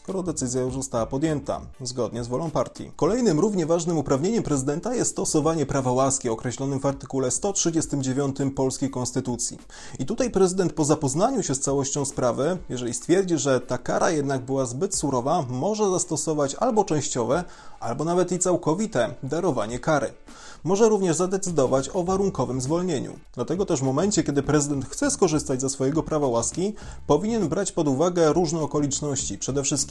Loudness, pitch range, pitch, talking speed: -24 LUFS, 135-175 Hz, 145 Hz, 155 wpm